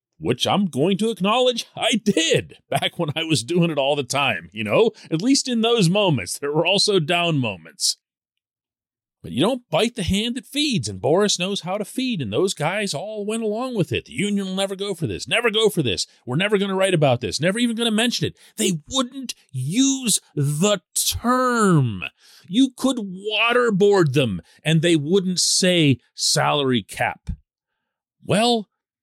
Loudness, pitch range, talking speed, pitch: -20 LUFS, 155-225 Hz, 185 wpm, 195 Hz